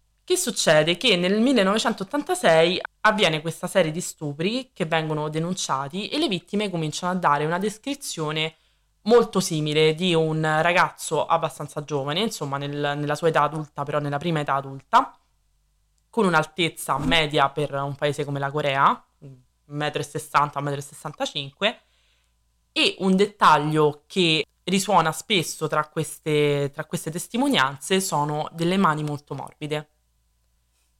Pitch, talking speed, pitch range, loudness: 155 Hz, 130 wpm, 145-185 Hz, -23 LUFS